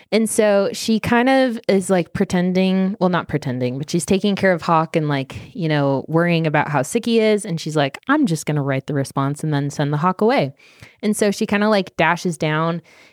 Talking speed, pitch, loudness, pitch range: 235 wpm, 175 Hz, -19 LUFS, 150-205 Hz